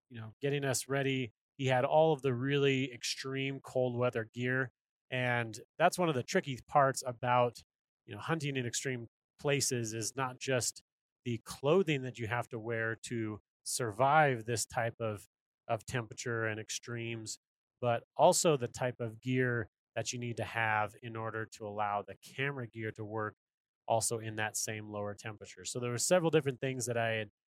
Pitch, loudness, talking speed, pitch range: 120 Hz, -34 LUFS, 180 wpm, 110-130 Hz